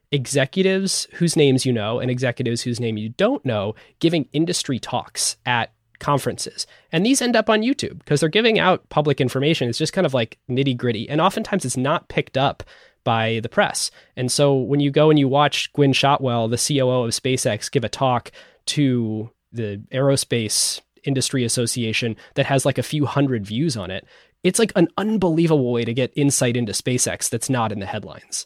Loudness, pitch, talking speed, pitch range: -20 LUFS, 130 Hz, 190 wpm, 120-155 Hz